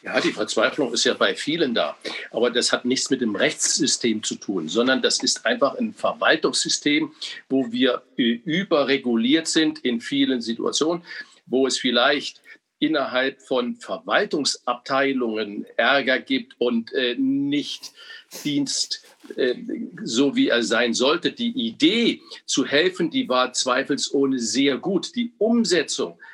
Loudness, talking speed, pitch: -22 LUFS, 135 wpm, 140 Hz